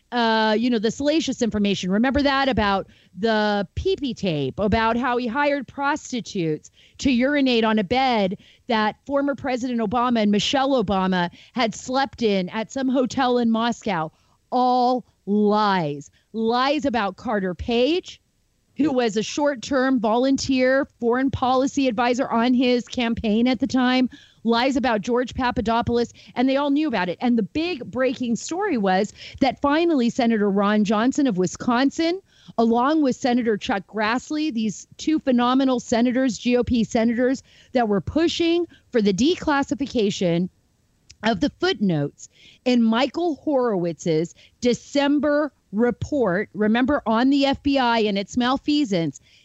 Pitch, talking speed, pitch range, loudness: 245 Hz, 135 wpm, 215-270 Hz, -22 LUFS